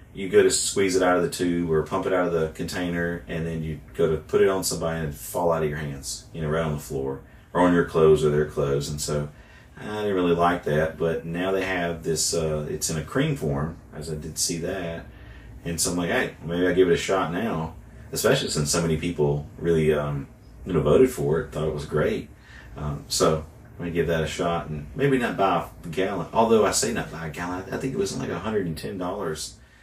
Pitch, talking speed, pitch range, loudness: 80 Hz, 255 wpm, 75-90 Hz, -25 LUFS